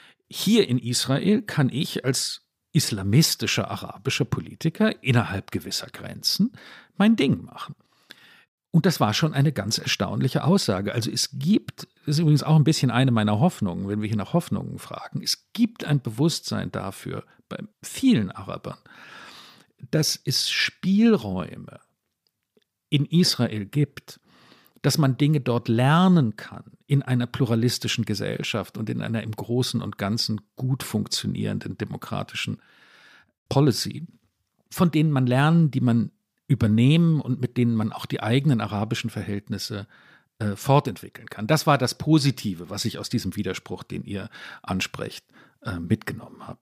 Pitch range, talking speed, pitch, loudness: 110-155 Hz, 140 wpm, 130 Hz, -24 LUFS